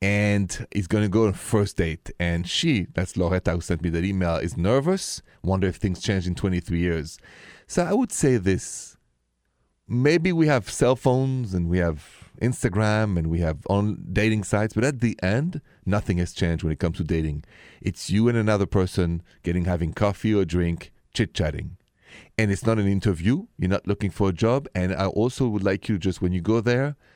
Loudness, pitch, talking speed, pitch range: -24 LUFS, 100 Hz, 205 wpm, 90-110 Hz